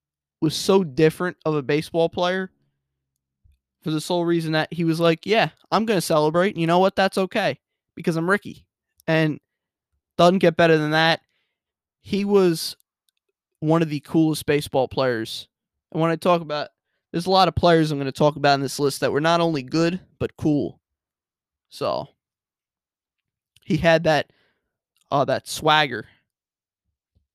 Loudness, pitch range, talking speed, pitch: -21 LUFS, 130-175 Hz, 160 wpm, 160 Hz